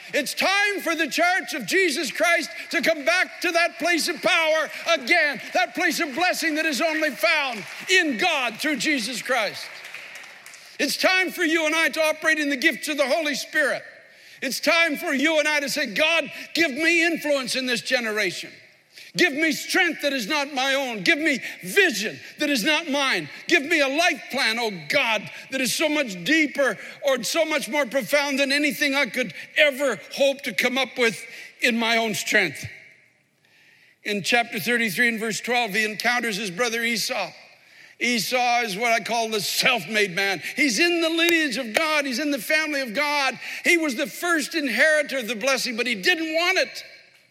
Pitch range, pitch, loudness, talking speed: 245-325 Hz, 295 Hz, -22 LUFS, 190 wpm